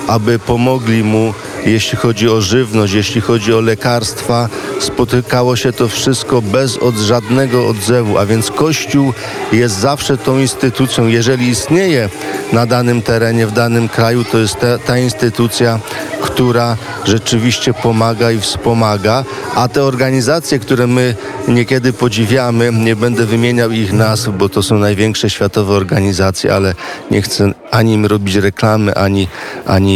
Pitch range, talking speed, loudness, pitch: 110-125 Hz, 140 wpm, -12 LUFS, 115 Hz